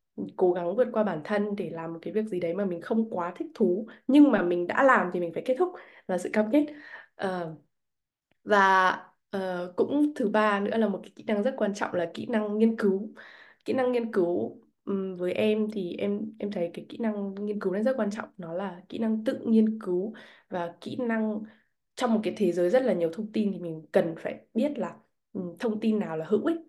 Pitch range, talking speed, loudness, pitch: 180-225 Hz, 235 wpm, -28 LUFS, 210 Hz